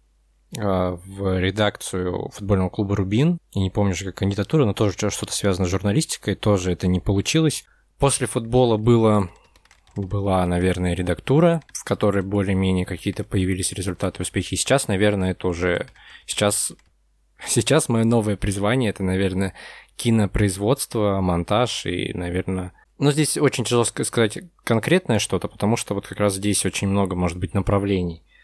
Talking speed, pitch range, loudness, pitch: 140 wpm, 95-115 Hz, -22 LUFS, 100 Hz